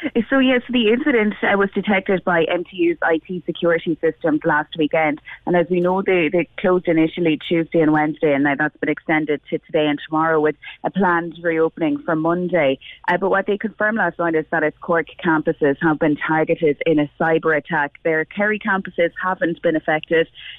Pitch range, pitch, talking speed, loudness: 155-185 Hz, 165 Hz, 185 wpm, -19 LUFS